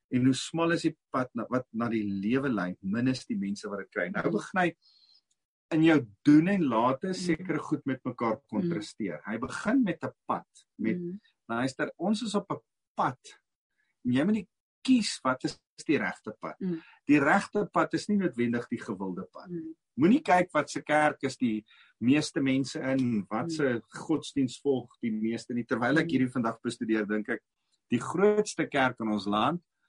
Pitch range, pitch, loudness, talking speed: 120-175 Hz, 145 Hz, -29 LUFS, 190 wpm